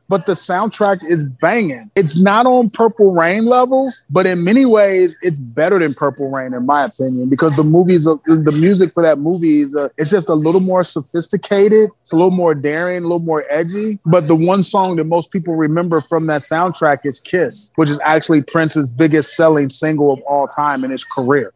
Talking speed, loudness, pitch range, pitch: 210 wpm, -14 LUFS, 150-190 Hz, 165 Hz